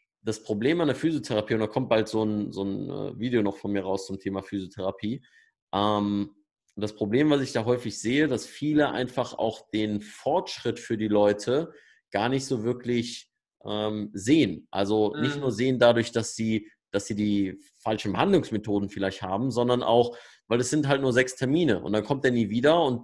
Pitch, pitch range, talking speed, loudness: 110 Hz, 105-125 Hz, 195 wpm, -26 LUFS